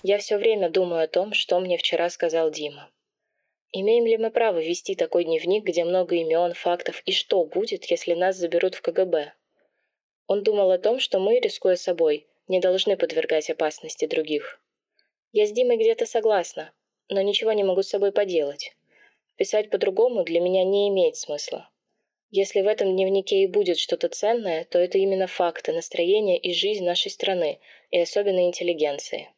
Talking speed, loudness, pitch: 170 wpm, -23 LUFS, 200 Hz